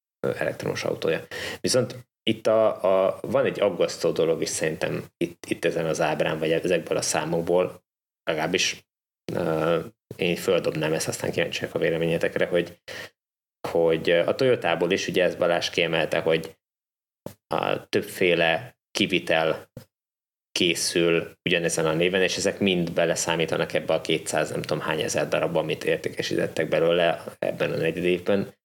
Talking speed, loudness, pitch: 140 wpm, -24 LUFS, 125 Hz